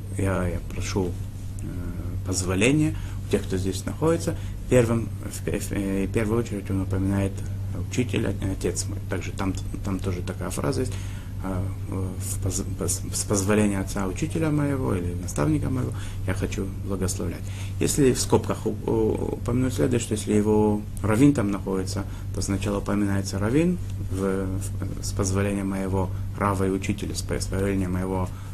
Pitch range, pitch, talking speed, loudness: 95-100 Hz, 100 Hz, 130 wpm, -26 LUFS